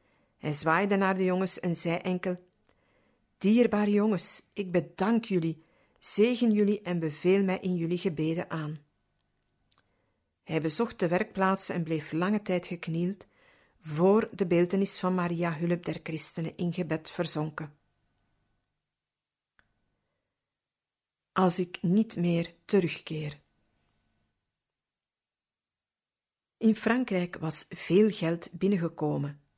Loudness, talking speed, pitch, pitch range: -29 LUFS, 110 wpm, 175 Hz, 160-195 Hz